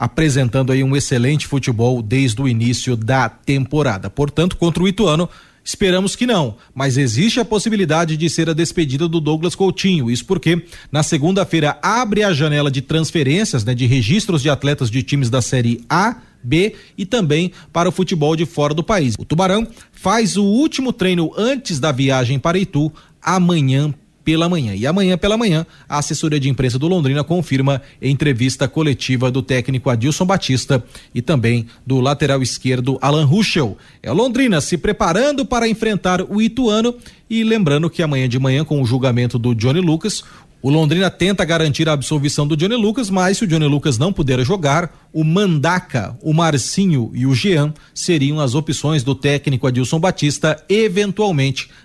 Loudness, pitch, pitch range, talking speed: -17 LUFS, 155 Hz, 135-185 Hz, 170 wpm